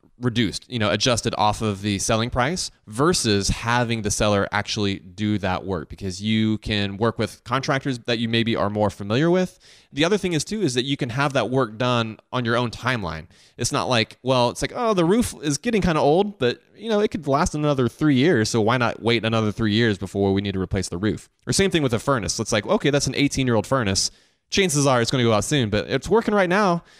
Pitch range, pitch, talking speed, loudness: 105-140 Hz, 120 Hz, 250 wpm, -22 LUFS